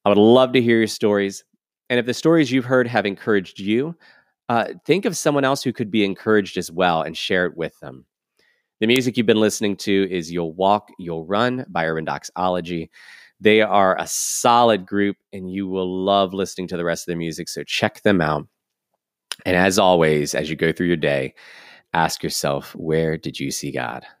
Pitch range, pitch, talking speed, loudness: 85-115 Hz, 100 Hz, 205 wpm, -20 LUFS